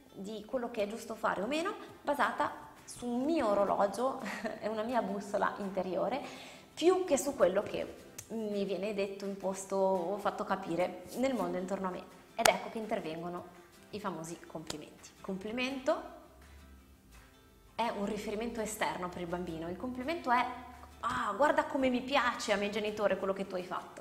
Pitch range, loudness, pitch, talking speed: 185-245 Hz, -34 LUFS, 210 Hz, 165 wpm